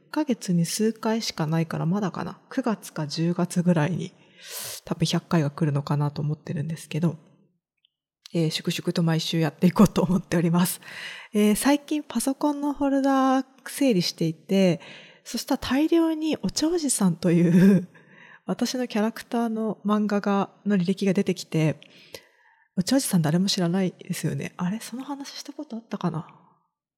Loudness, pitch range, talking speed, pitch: -25 LUFS, 170-235 Hz, 320 characters per minute, 185 Hz